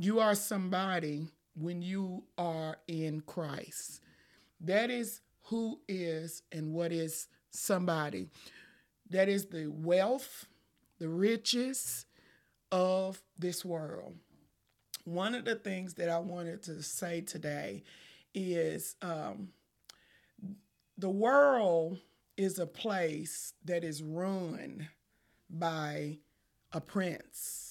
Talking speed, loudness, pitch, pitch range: 105 wpm, -35 LUFS, 175 Hz, 160-195 Hz